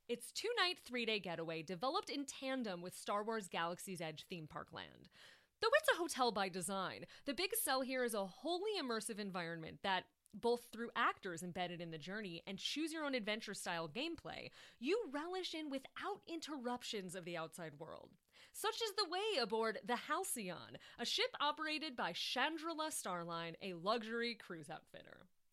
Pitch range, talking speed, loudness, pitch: 185-305 Hz, 155 wpm, -42 LUFS, 230 Hz